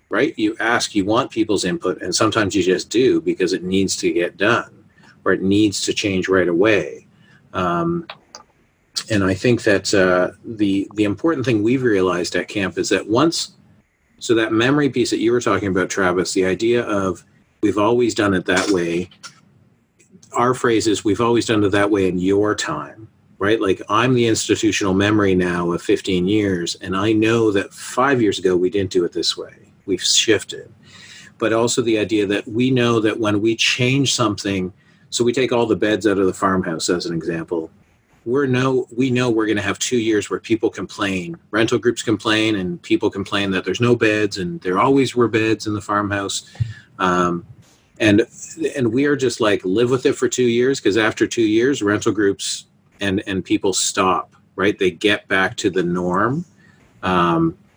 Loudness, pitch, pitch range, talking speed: -18 LUFS, 110 Hz, 95-130 Hz, 190 wpm